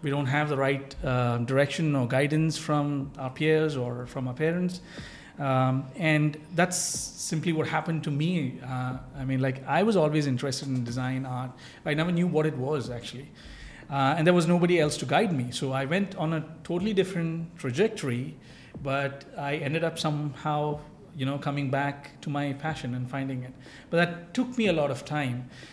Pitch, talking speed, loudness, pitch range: 145 Hz, 190 wpm, -28 LUFS, 130-160 Hz